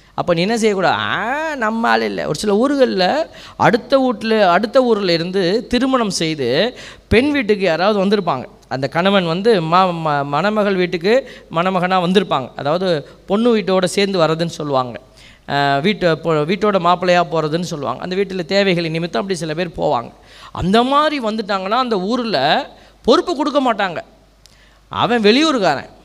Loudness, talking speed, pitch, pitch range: -16 LUFS, 140 wpm, 195 Hz, 170-230 Hz